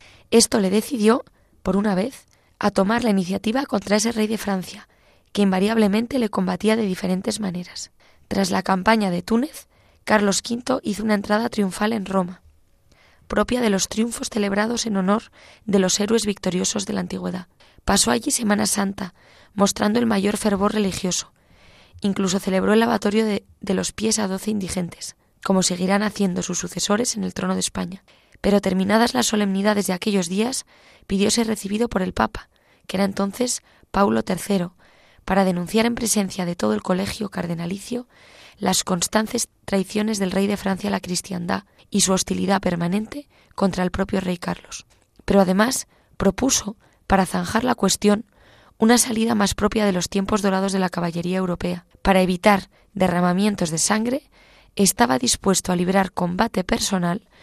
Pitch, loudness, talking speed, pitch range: 200 Hz, -21 LUFS, 160 wpm, 185-215 Hz